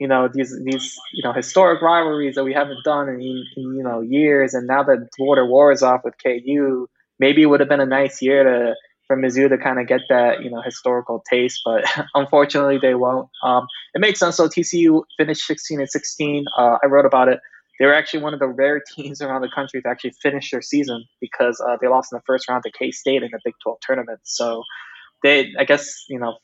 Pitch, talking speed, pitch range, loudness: 135 Hz, 235 wpm, 130-145 Hz, -18 LUFS